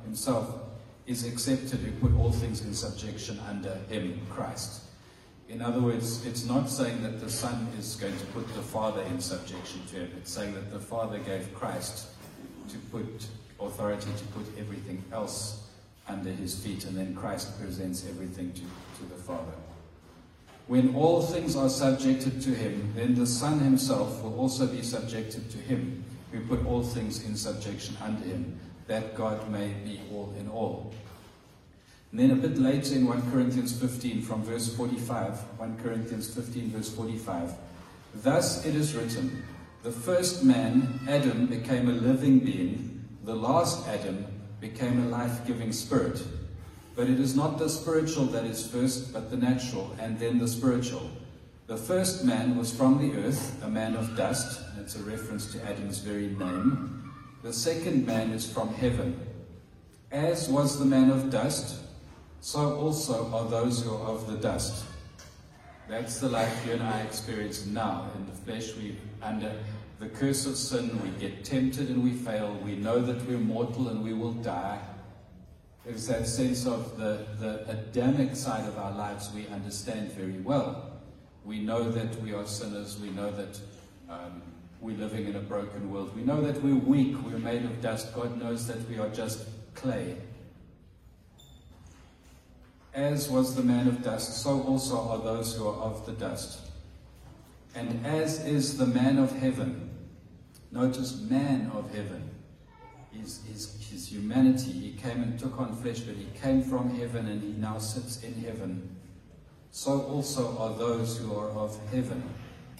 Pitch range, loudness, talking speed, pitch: 105-125 Hz, -30 LUFS, 165 wpm, 115 Hz